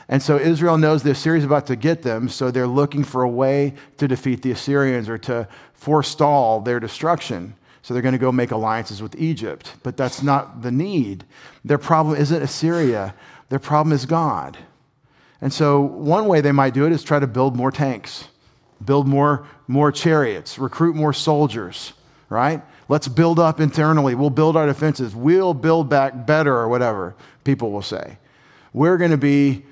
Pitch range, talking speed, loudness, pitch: 125-155 Hz, 185 wpm, -19 LUFS, 140 Hz